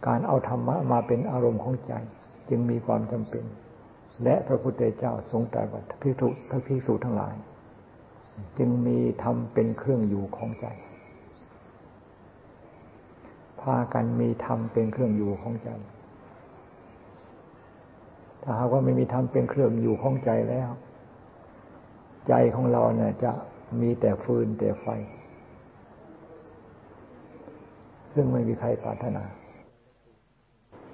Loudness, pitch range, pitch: -27 LUFS, 105-125 Hz, 115 Hz